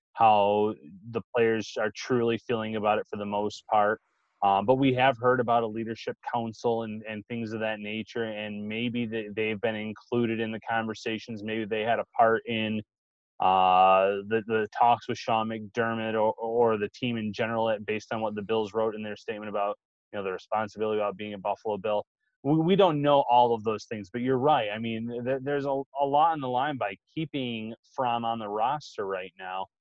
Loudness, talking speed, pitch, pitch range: -28 LUFS, 210 wpm, 110 Hz, 105-120 Hz